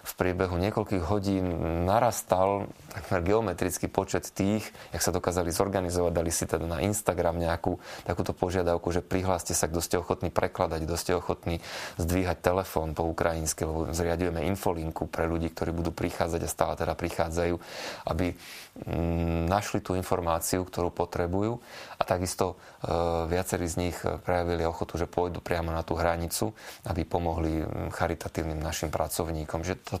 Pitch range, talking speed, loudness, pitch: 85-95 Hz, 145 wpm, -29 LUFS, 90 Hz